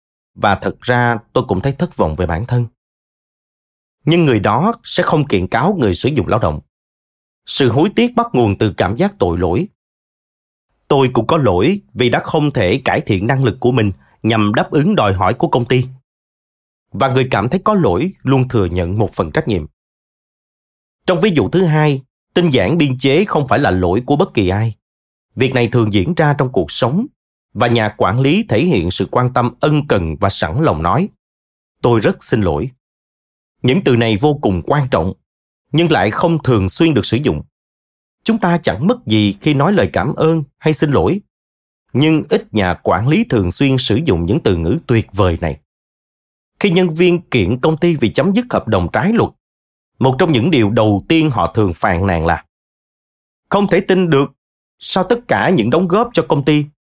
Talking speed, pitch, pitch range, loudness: 200 wpm, 125 Hz, 95-155 Hz, -15 LUFS